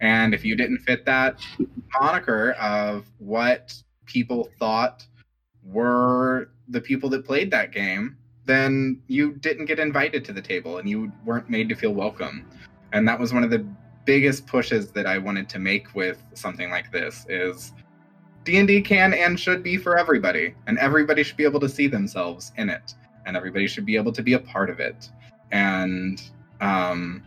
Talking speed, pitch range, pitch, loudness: 180 wpm, 105-140 Hz, 125 Hz, -23 LUFS